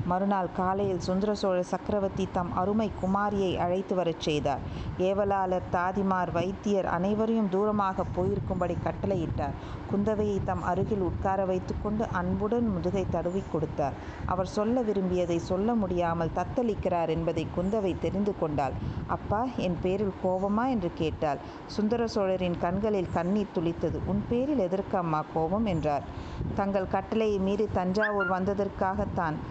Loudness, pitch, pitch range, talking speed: -29 LUFS, 190 Hz, 175-205 Hz, 120 wpm